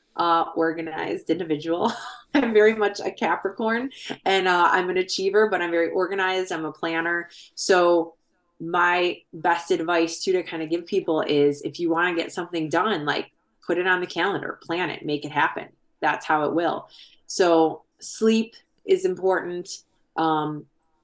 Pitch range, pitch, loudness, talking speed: 165-190 Hz, 175 Hz, -23 LUFS, 165 wpm